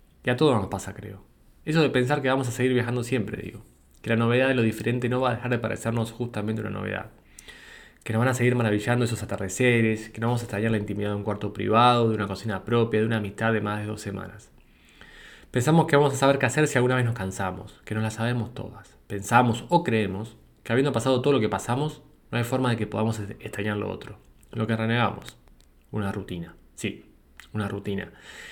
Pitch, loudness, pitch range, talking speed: 110 Hz, -25 LUFS, 105-125 Hz, 225 wpm